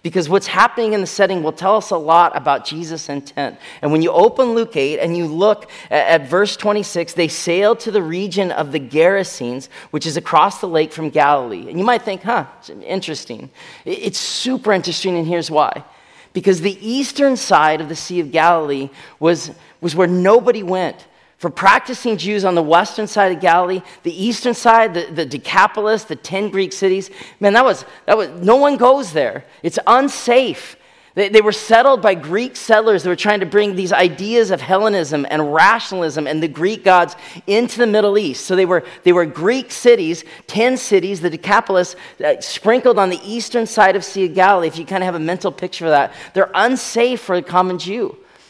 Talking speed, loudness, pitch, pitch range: 200 wpm, -16 LUFS, 190 Hz, 170-215 Hz